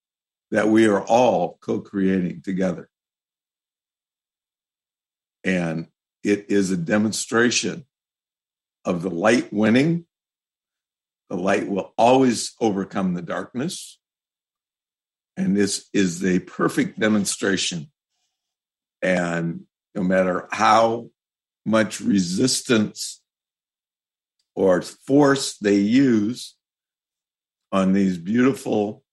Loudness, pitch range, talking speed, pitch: -21 LUFS, 95-115 Hz, 85 wpm, 100 Hz